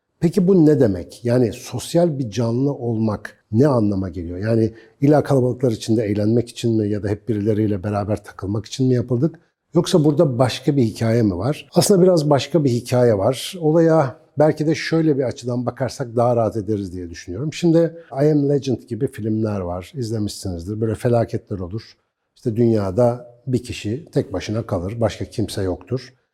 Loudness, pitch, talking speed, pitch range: -20 LUFS, 120 Hz, 170 wpm, 110-140 Hz